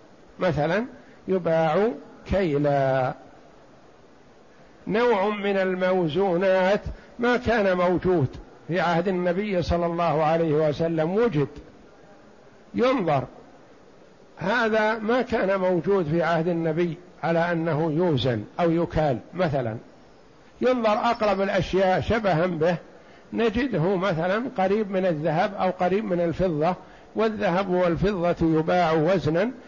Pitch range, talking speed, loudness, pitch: 165-200 Hz, 100 wpm, -24 LUFS, 180 Hz